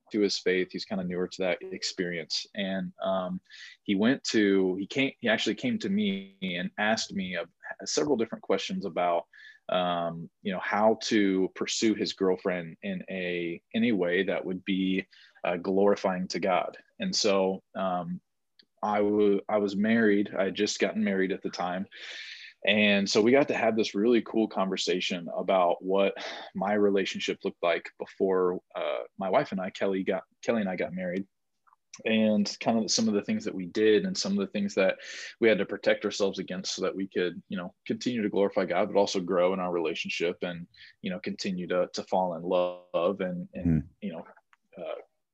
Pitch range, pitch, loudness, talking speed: 95-110 Hz, 100 Hz, -28 LUFS, 195 wpm